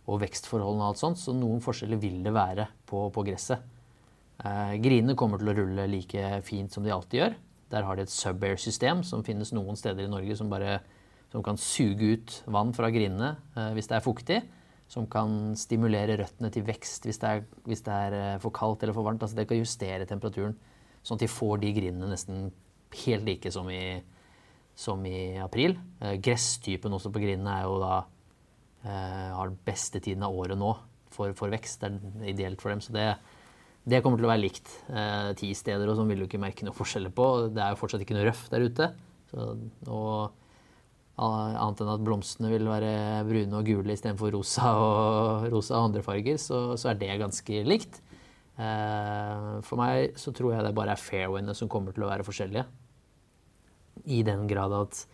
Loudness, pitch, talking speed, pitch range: -30 LUFS, 105 Hz, 200 wpm, 100-115 Hz